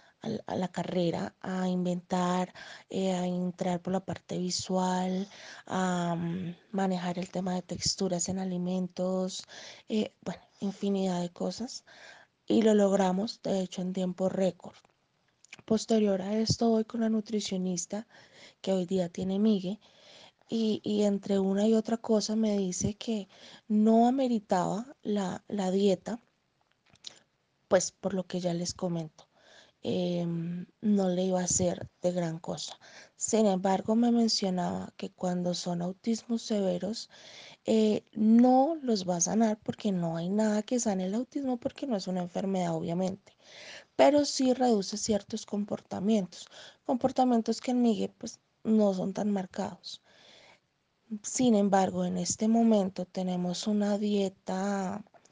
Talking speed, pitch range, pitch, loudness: 140 wpm, 180-220 Hz, 195 Hz, -30 LUFS